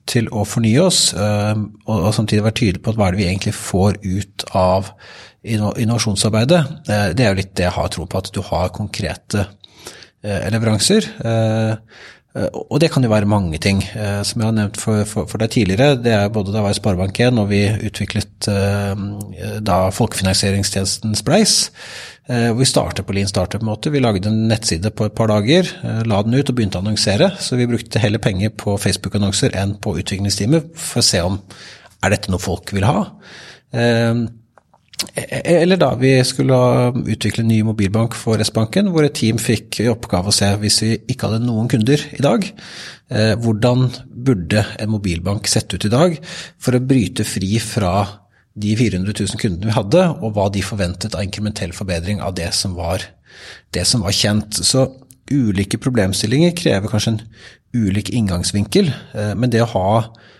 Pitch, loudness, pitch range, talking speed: 110 Hz, -17 LUFS, 100-120 Hz, 175 wpm